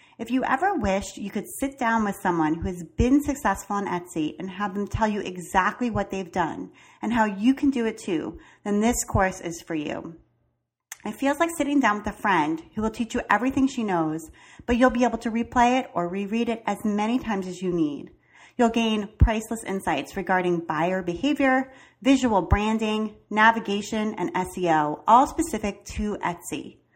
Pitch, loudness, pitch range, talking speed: 210 Hz, -25 LUFS, 185-240 Hz, 190 wpm